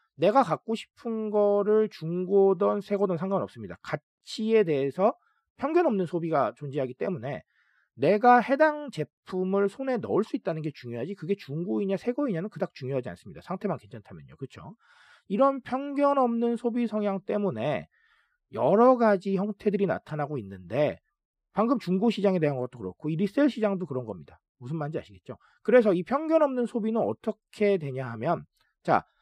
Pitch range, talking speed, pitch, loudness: 155-235 Hz, 355 characters per minute, 200 Hz, -27 LUFS